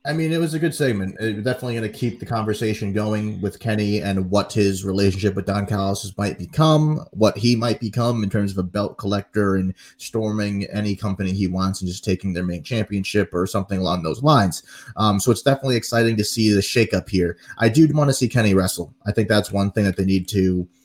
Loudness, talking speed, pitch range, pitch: -21 LUFS, 230 wpm, 95-115 Hz, 105 Hz